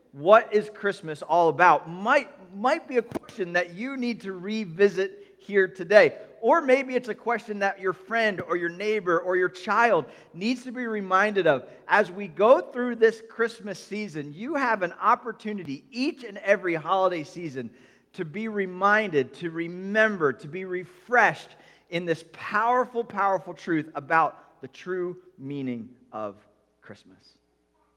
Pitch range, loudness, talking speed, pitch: 170-220 Hz, -25 LUFS, 150 wpm, 195 Hz